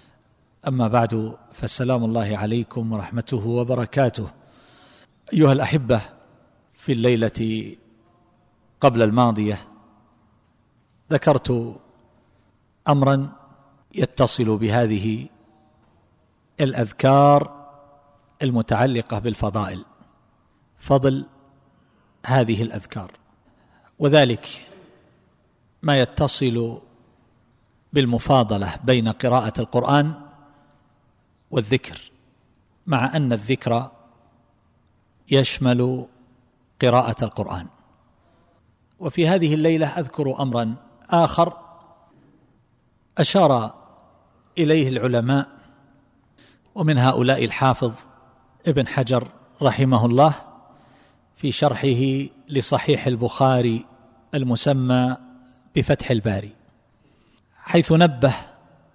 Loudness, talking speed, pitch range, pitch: -21 LUFS, 65 wpm, 115-140 Hz, 125 Hz